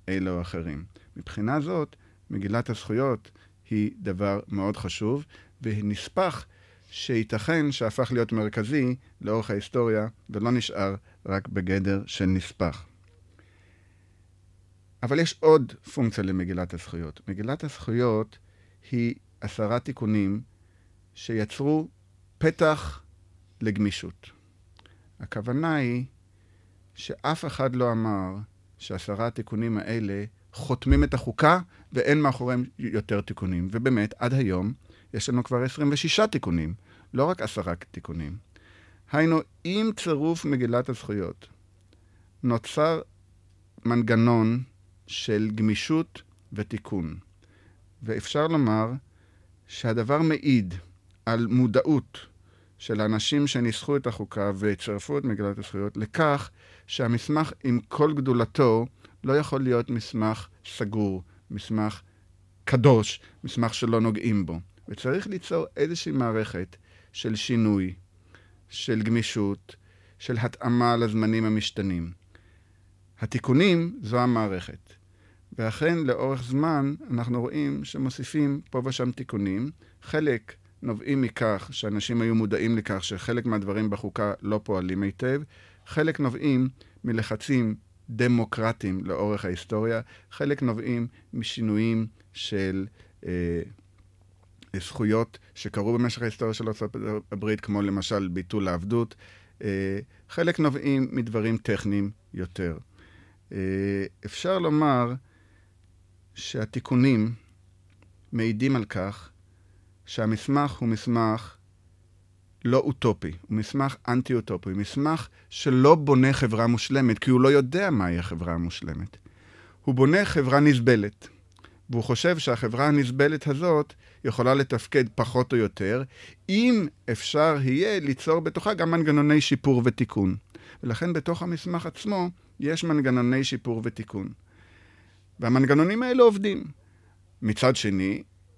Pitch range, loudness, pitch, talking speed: 95-125 Hz, -26 LUFS, 110 Hz, 100 wpm